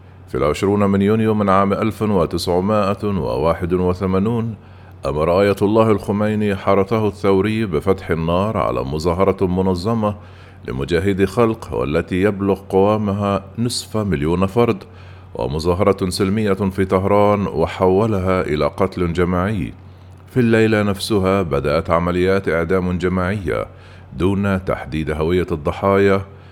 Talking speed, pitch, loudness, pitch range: 100 wpm, 95 Hz, -18 LUFS, 90-105 Hz